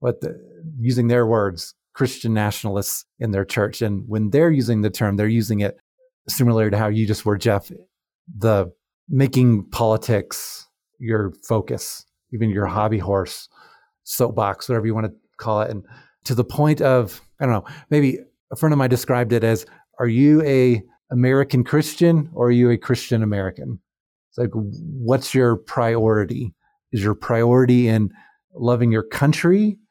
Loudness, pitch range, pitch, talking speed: -20 LUFS, 105-130 Hz, 120 Hz, 165 wpm